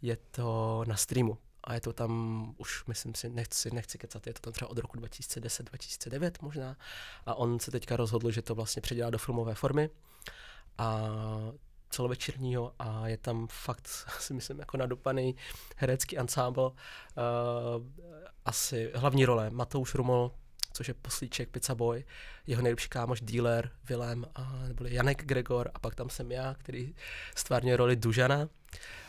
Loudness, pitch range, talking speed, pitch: -34 LUFS, 115-130 Hz, 155 wpm, 120 Hz